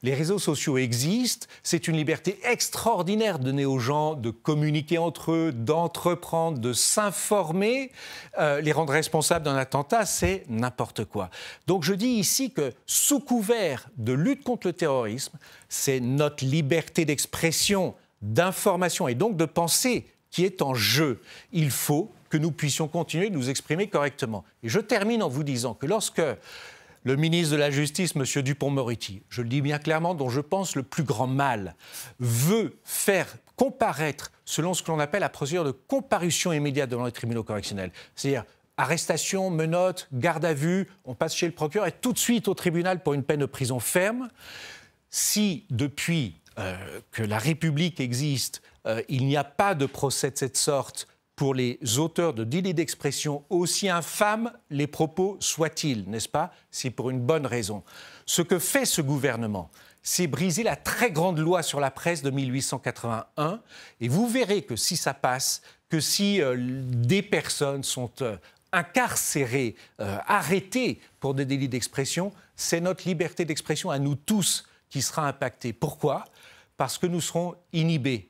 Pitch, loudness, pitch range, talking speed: 155 Hz, -26 LUFS, 135-180 Hz, 170 wpm